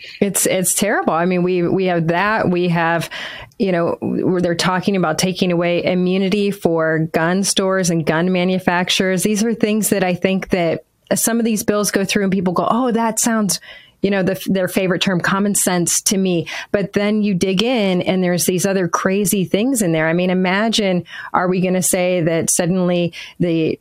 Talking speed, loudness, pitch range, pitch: 200 wpm, -17 LUFS, 175-200 Hz, 185 Hz